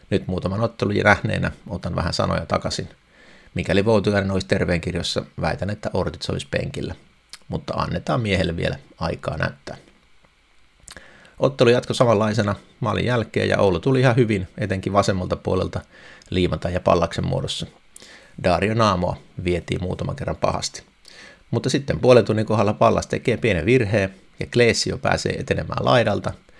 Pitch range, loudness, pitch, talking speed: 95-115 Hz, -21 LUFS, 105 Hz, 135 wpm